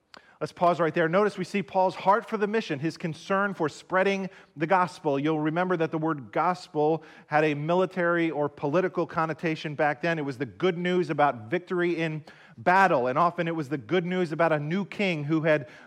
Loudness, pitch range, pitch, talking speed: -26 LUFS, 155-185 Hz, 170 Hz, 205 wpm